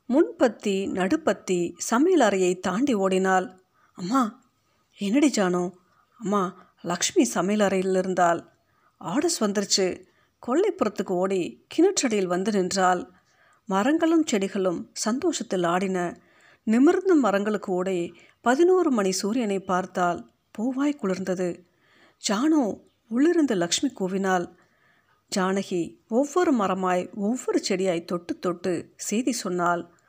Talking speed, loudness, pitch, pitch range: 95 wpm, -24 LUFS, 200 Hz, 185-260 Hz